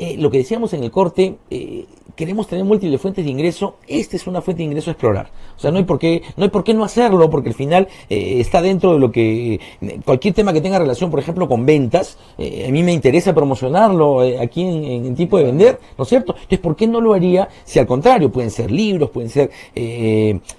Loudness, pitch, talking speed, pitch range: -16 LUFS, 170 Hz, 245 wpm, 135-190 Hz